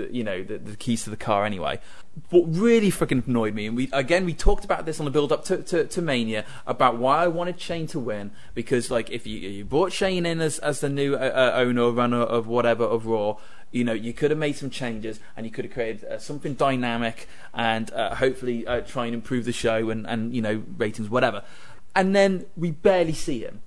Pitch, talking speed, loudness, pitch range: 125 Hz, 235 wpm, -25 LUFS, 115-155 Hz